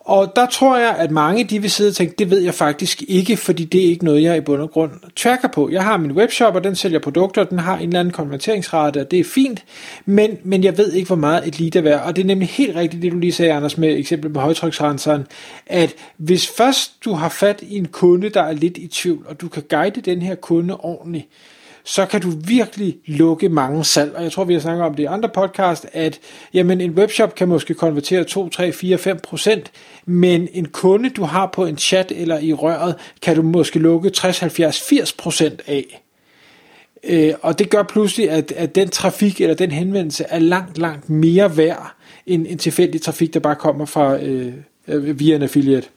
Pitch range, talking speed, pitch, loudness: 160-195 Hz, 225 wpm, 175 Hz, -17 LUFS